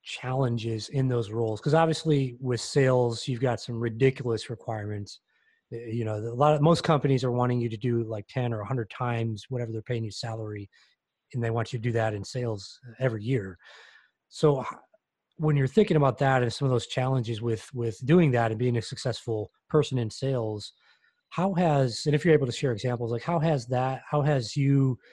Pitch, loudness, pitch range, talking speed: 125 Hz, -27 LUFS, 115-135 Hz, 200 wpm